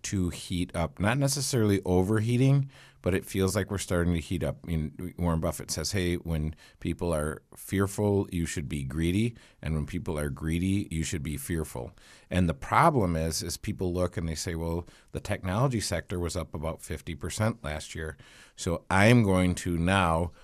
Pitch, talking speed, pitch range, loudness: 90 Hz, 190 wpm, 80-100 Hz, -29 LUFS